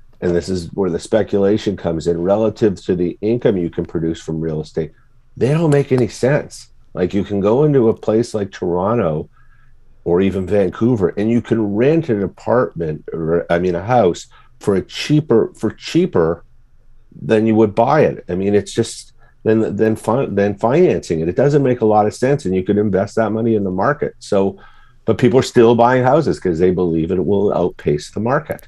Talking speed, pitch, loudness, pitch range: 200 wpm, 110 Hz, -17 LUFS, 90-120 Hz